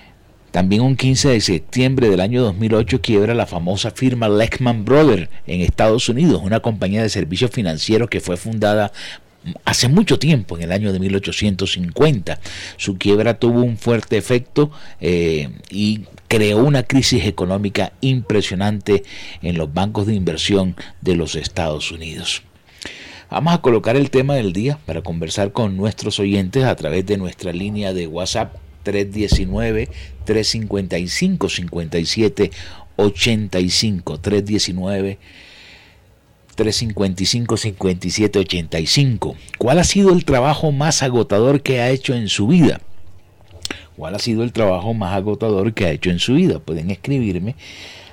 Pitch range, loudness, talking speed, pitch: 90-115 Hz, -18 LUFS, 135 wpm, 105 Hz